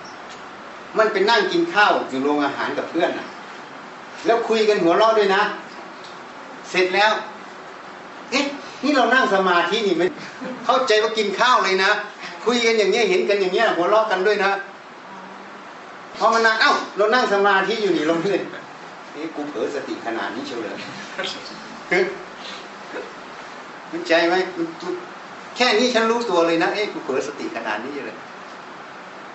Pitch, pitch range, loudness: 215 Hz, 195-245 Hz, -19 LUFS